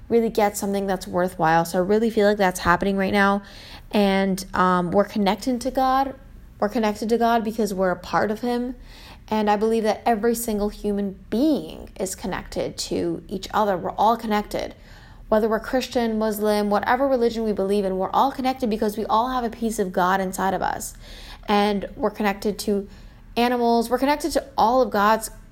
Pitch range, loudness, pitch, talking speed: 200-235 Hz, -22 LUFS, 210 Hz, 190 wpm